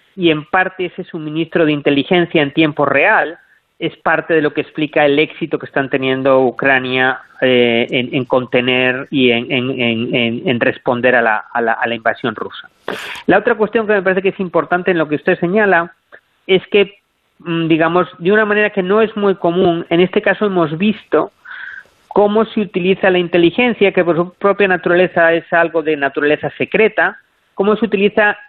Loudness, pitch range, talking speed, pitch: -14 LUFS, 150-195 Hz, 185 wpm, 170 Hz